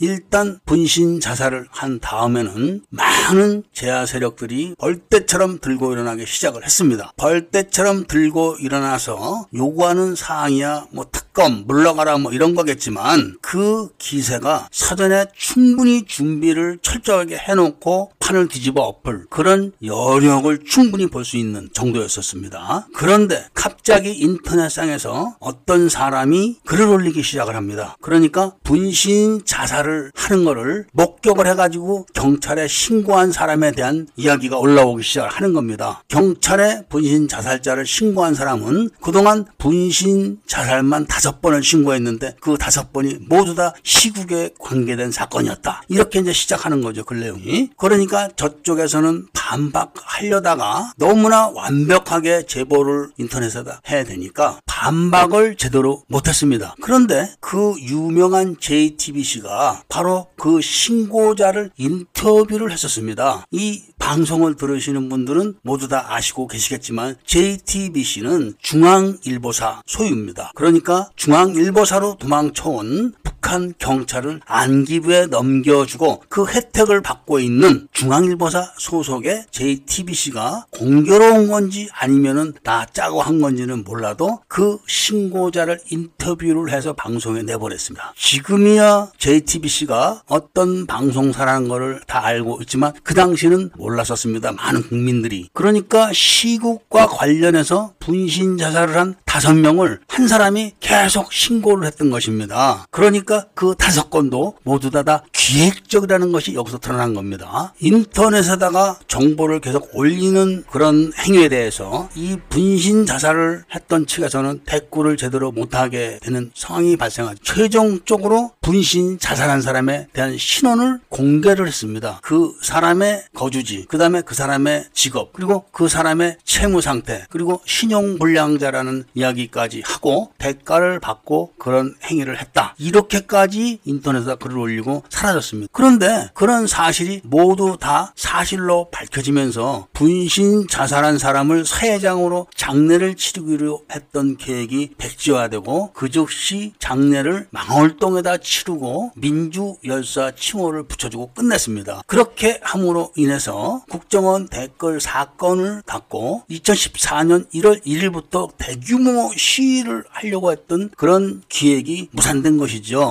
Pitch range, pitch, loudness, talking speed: 135-190 Hz, 160 Hz, -17 LUFS, 310 characters per minute